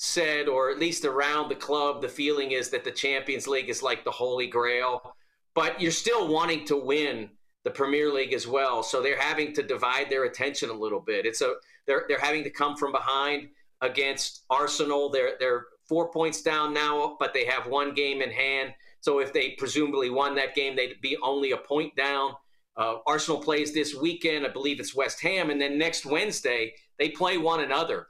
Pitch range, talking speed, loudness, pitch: 140-165 Hz, 205 wpm, -27 LUFS, 150 Hz